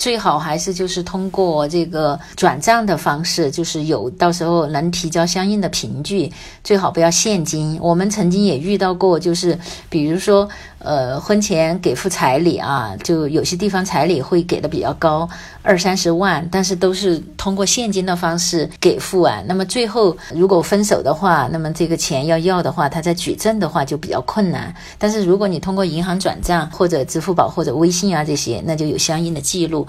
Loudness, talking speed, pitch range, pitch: -17 LUFS, 295 characters per minute, 160-190 Hz, 175 Hz